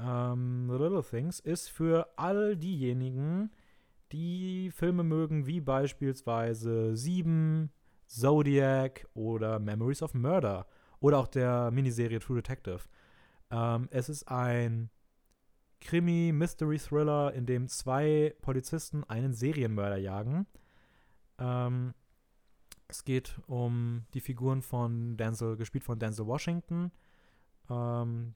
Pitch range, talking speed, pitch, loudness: 120-155 Hz, 105 wpm, 130 Hz, -32 LUFS